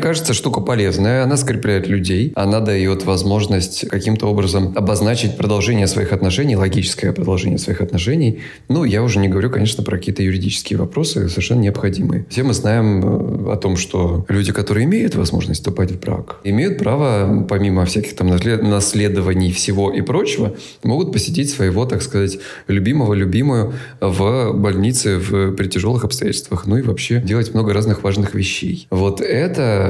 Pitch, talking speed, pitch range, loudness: 100 Hz, 155 wpm, 95-110 Hz, -17 LUFS